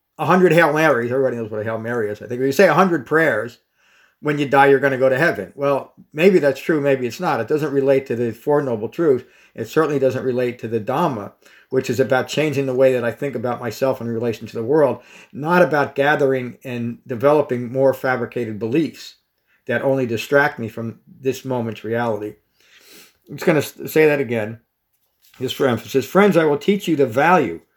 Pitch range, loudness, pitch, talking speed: 120-145 Hz, -19 LUFS, 130 Hz, 210 wpm